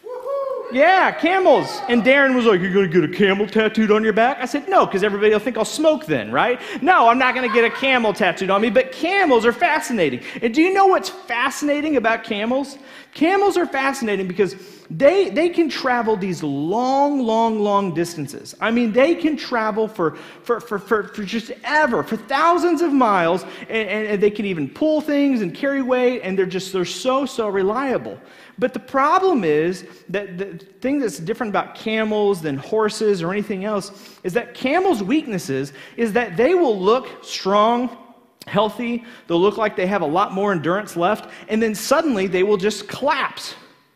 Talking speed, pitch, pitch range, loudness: 190 wpm, 230 Hz, 200-270 Hz, -19 LUFS